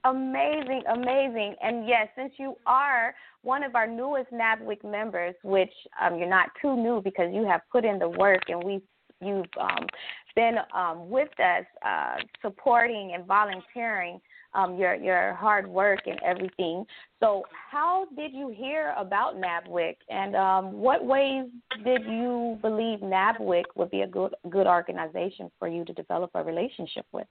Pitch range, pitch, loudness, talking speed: 185-255 Hz, 215 Hz, -27 LUFS, 160 wpm